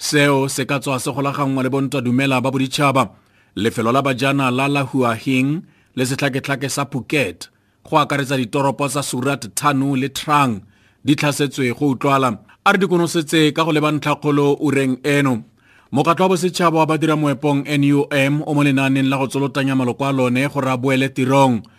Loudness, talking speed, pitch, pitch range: -18 LUFS, 185 wpm, 140 Hz, 130-145 Hz